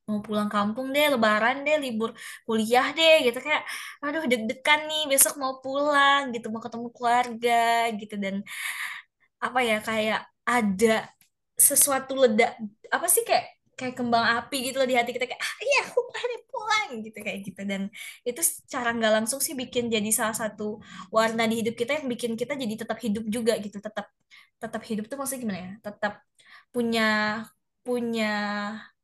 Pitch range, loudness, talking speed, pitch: 215-270 Hz, -25 LUFS, 170 wpm, 235 Hz